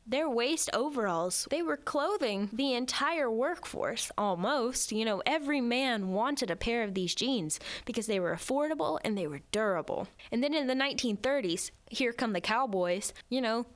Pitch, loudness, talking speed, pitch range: 235 Hz, -31 LUFS, 170 wpm, 200-265 Hz